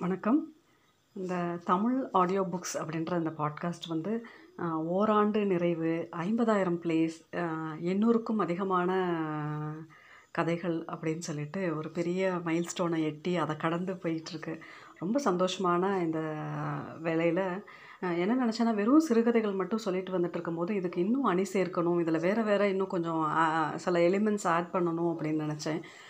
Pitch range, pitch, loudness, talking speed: 165-195 Hz, 175 Hz, -30 LUFS, 120 wpm